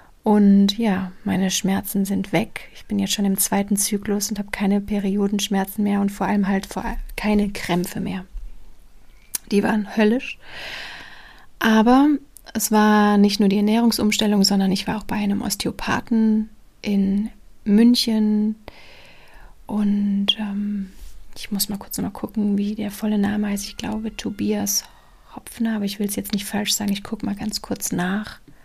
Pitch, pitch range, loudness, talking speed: 205 Hz, 200-215 Hz, -21 LUFS, 160 wpm